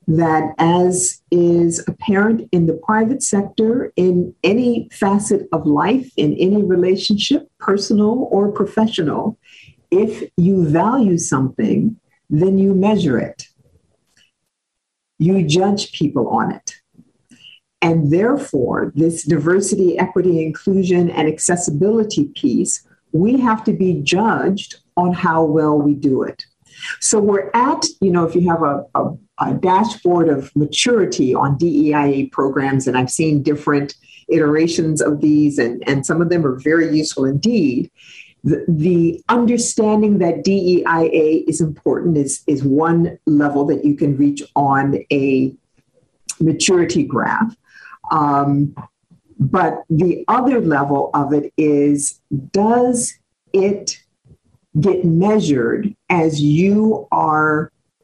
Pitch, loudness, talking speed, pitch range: 170 Hz, -16 LUFS, 125 wpm, 150-200 Hz